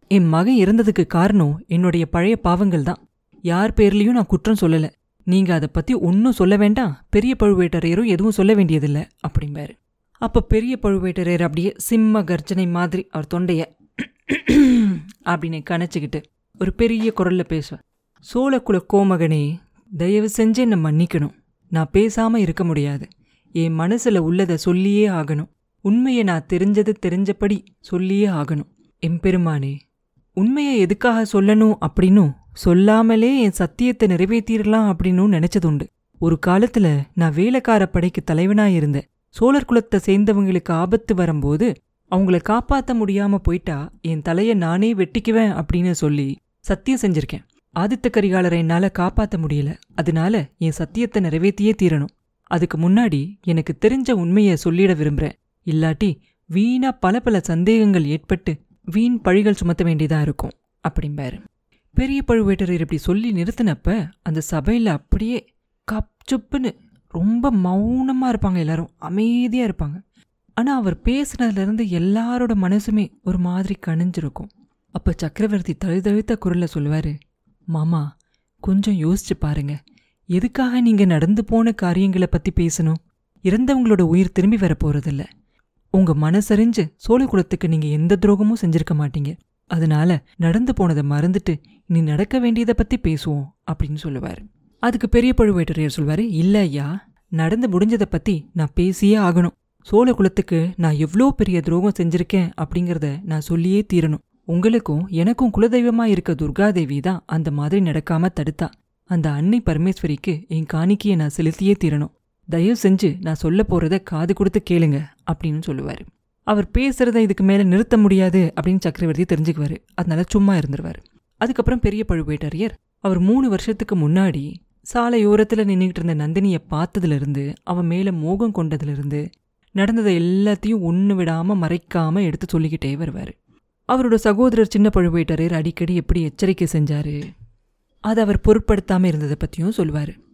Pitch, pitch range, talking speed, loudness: 185 Hz, 165-210 Hz, 125 wpm, -19 LUFS